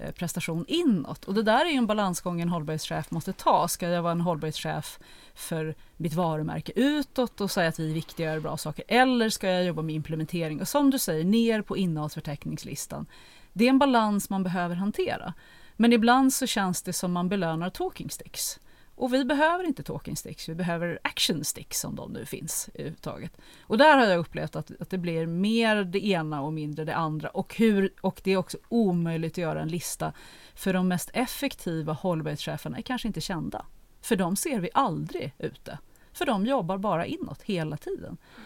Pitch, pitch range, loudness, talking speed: 180 Hz, 160-220 Hz, -27 LUFS, 200 wpm